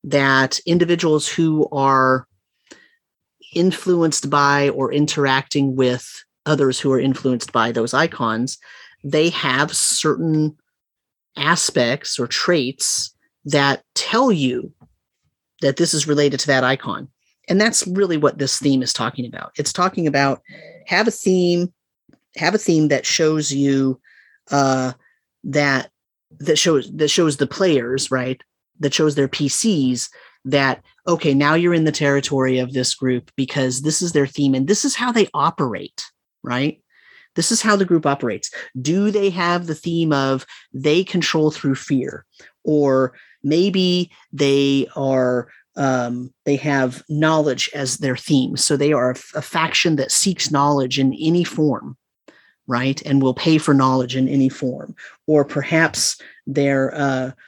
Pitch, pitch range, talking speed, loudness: 145 Hz, 130-165 Hz, 145 wpm, -18 LUFS